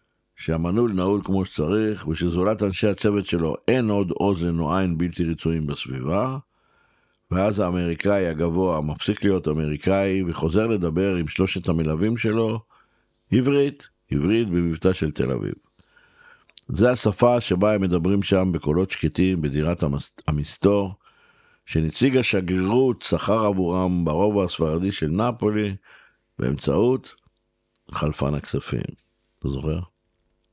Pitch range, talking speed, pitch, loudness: 85-105 Hz, 110 wpm, 95 Hz, -23 LUFS